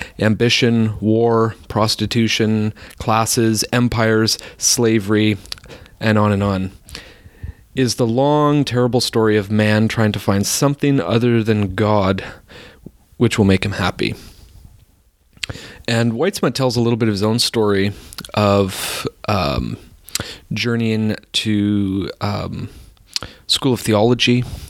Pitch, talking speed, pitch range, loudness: 110 Hz, 115 wpm, 100-120 Hz, -17 LUFS